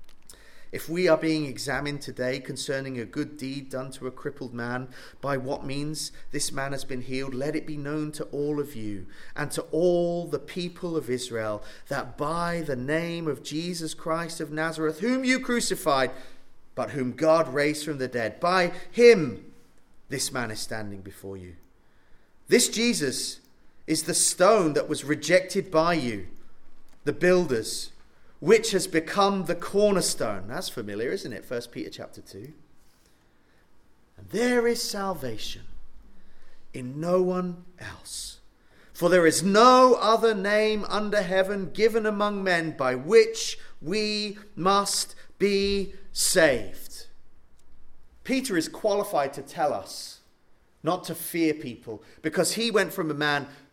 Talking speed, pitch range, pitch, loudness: 145 wpm, 130-190 Hz, 160 Hz, -26 LUFS